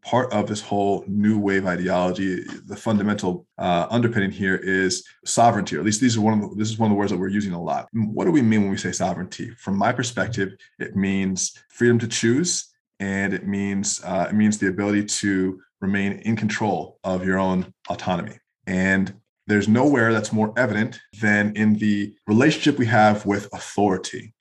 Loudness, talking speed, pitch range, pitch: -22 LUFS, 195 wpm, 95-110 Hz, 105 Hz